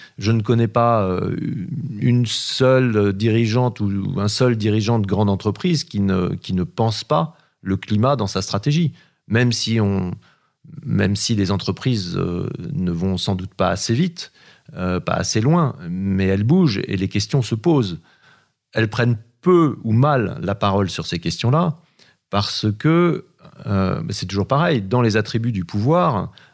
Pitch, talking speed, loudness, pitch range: 115 Hz, 160 wpm, -20 LUFS, 100-140 Hz